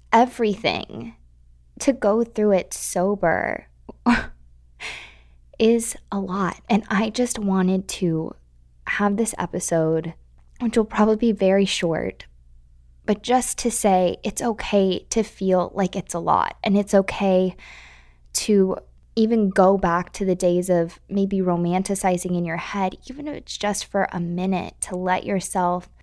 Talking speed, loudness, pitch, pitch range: 140 wpm, -22 LUFS, 185 Hz, 165-205 Hz